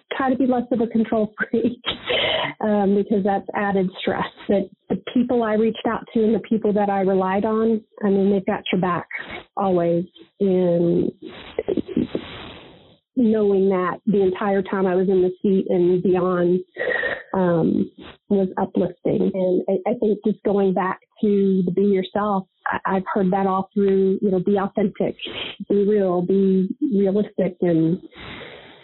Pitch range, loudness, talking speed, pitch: 190-215 Hz, -21 LUFS, 150 wpm, 200 Hz